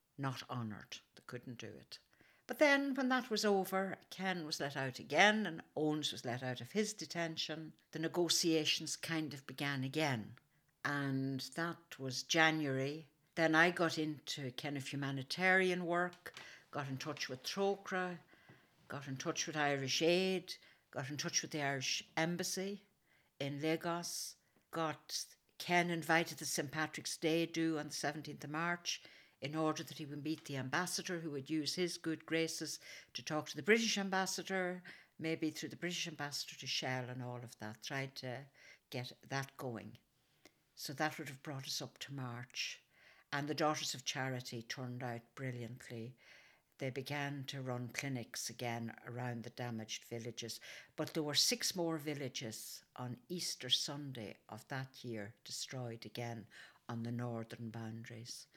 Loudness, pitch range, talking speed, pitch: -39 LUFS, 125-165 Hz, 160 wpm, 145 Hz